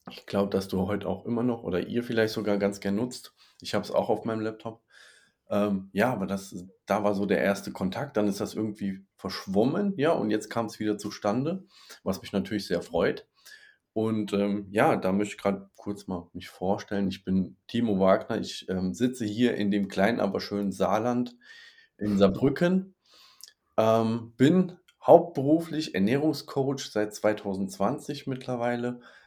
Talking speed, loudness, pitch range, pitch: 170 wpm, -28 LUFS, 100-120 Hz, 105 Hz